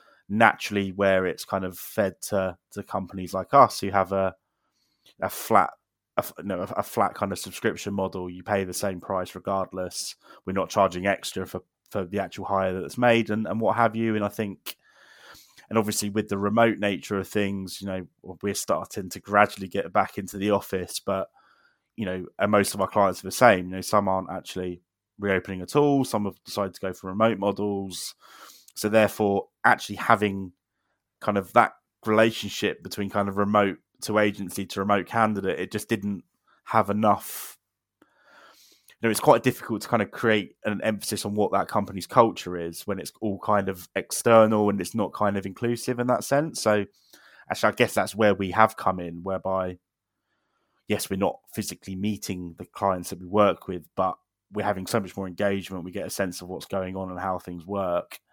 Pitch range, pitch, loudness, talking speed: 95-105 Hz, 100 Hz, -26 LUFS, 195 wpm